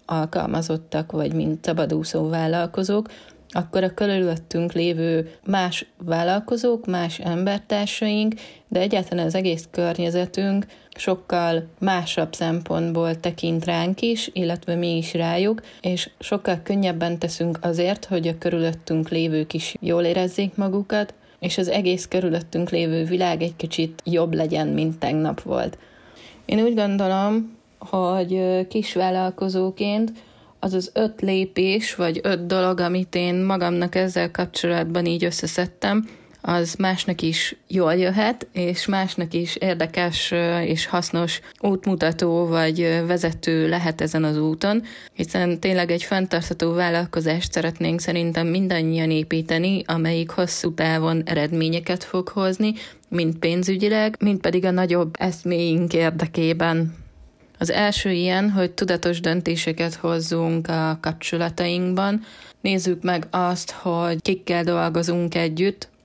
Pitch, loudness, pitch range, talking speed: 175 Hz, -22 LUFS, 165-185 Hz, 120 wpm